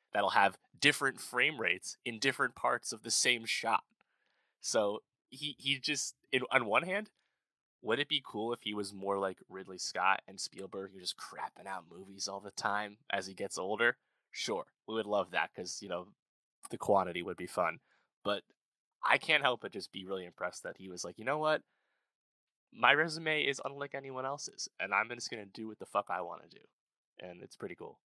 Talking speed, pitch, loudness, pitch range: 210 wpm, 110 Hz, -34 LUFS, 95-140 Hz